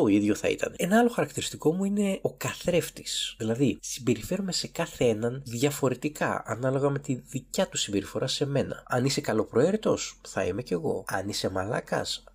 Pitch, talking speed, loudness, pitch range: 140 Hz, 170 wpm, -28 LUFS, 120-170 Hz